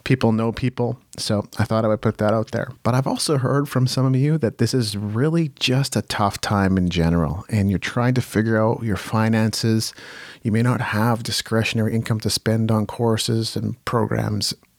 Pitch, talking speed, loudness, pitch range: 115 Hz, 205 wpm, -21 LUFS, 110-125 Hz